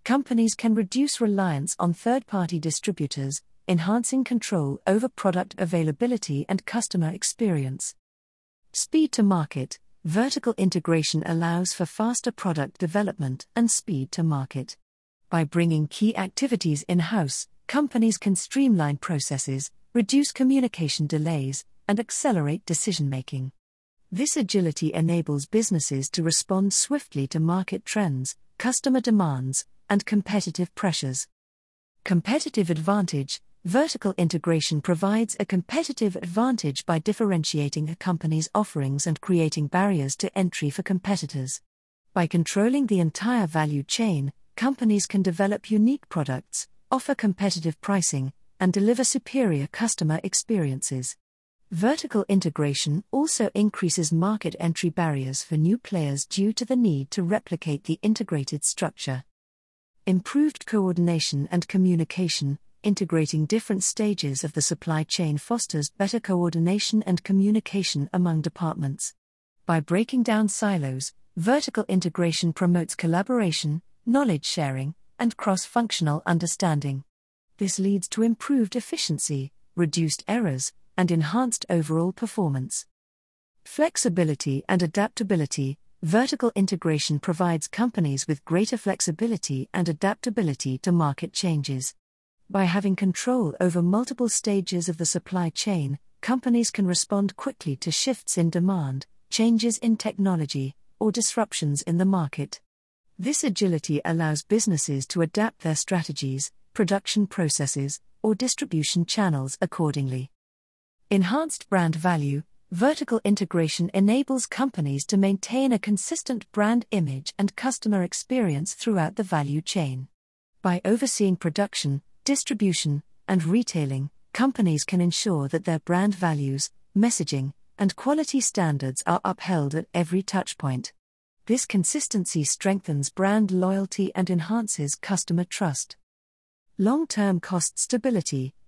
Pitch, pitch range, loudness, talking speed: 180 Hz, 155-215 Hz, -25 LUFS, 120 wpm